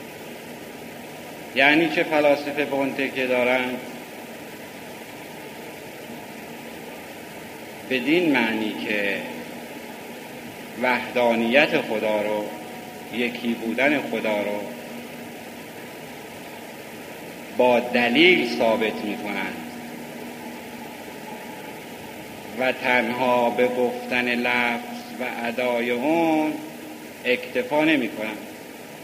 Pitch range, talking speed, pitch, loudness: 120-130 Hz, 65 wpm, 125 Hz, -22 LUFS